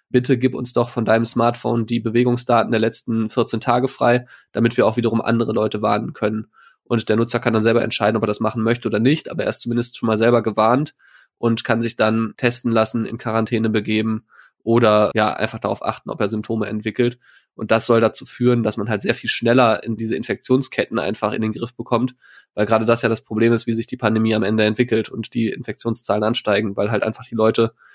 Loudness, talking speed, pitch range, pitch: -19 LUFS, 225 wpm, 110-120 Hz, 115 Hz